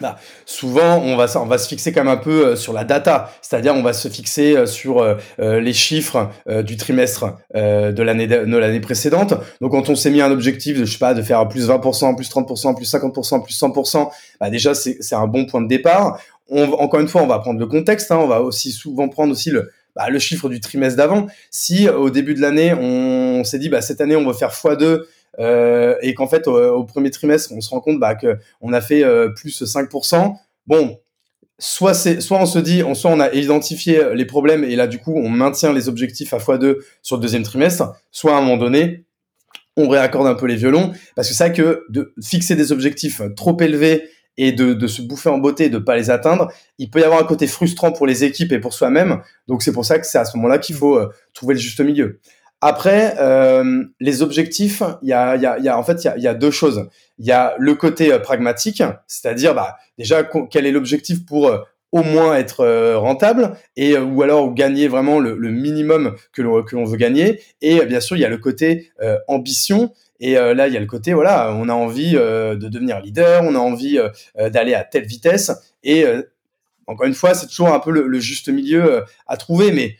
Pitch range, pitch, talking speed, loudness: 125-160 Hz, 140 Hz, 240 wpm, -16 LUFS